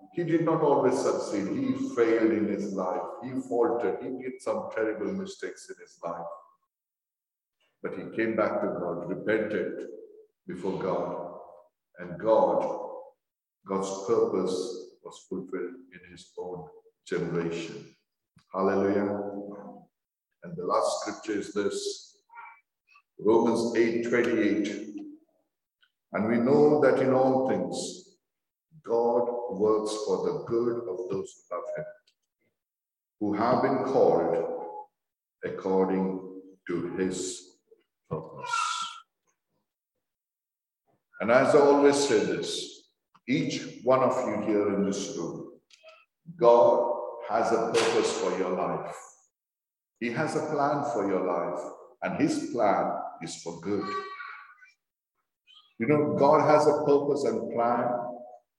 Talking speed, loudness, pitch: 120 wpm, -27 LUFS, 150 Hz